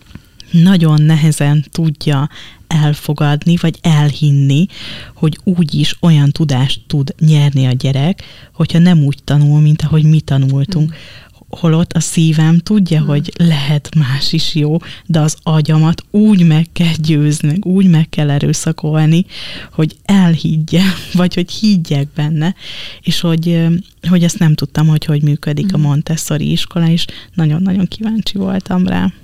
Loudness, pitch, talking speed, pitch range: -13 LUFS, 155 Hz, 135 wpm, 150-170 Hz